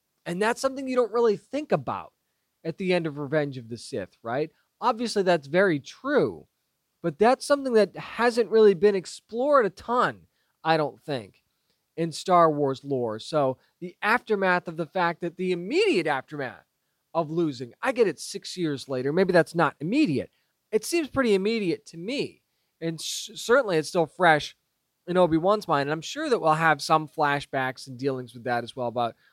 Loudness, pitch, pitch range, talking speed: -25 LUFS, 165 Hz, 140-210 Hz, 185 wpm